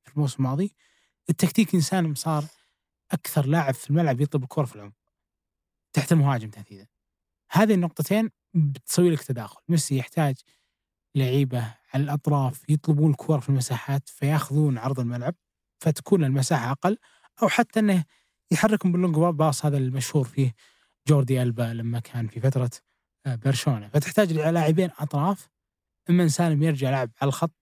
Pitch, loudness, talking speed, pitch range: 150 Hz, -24 LUFS, 135 wpm, 130-165 Hz